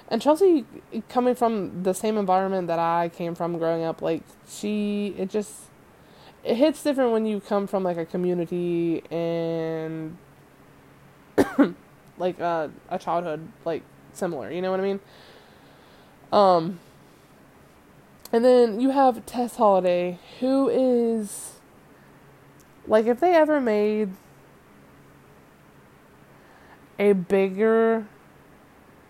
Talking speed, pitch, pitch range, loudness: 115 wpm, 200 Hz, 175-230 Hz, -24 LUFS